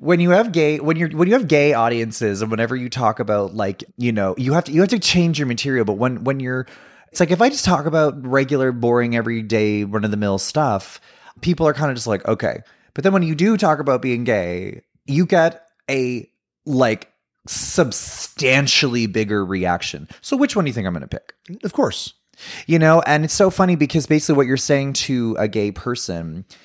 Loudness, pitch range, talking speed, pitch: -18 LUFS, 110-160 Hz, 220 wpm, 130 Hz